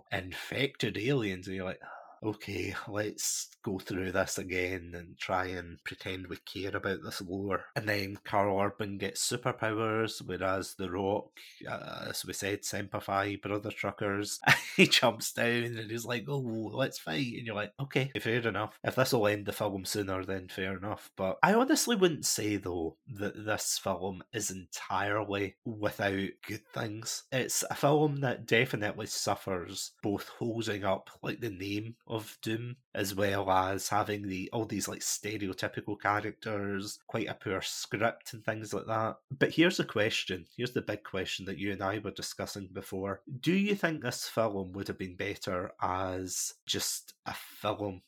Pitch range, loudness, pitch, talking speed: 95-115 Hz, -33 LUFS, 105 Hz, 170 wpm